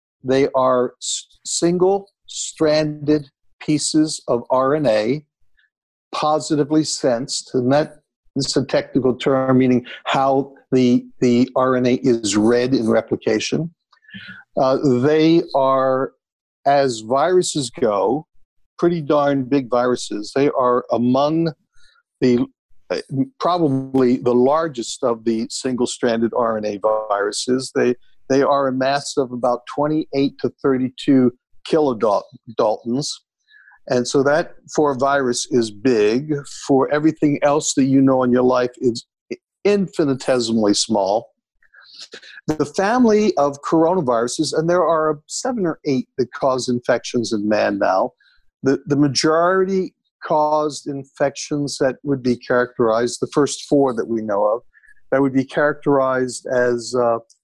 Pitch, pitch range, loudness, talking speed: 135 Hz, 125-150 Hz, -19 LUFS, 120 wpm